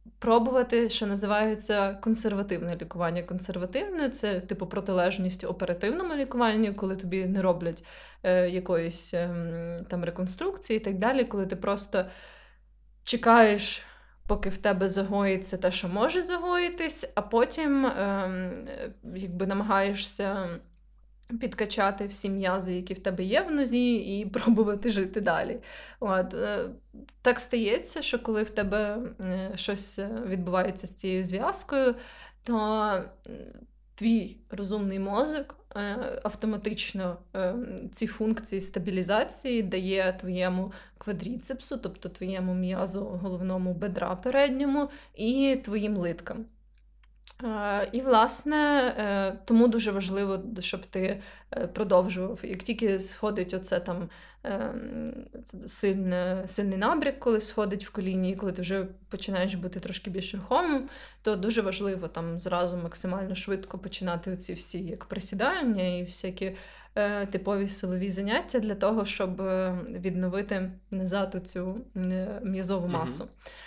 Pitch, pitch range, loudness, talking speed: 200 Hz, 185-225 Hz, -29 LUFS, 115 wpm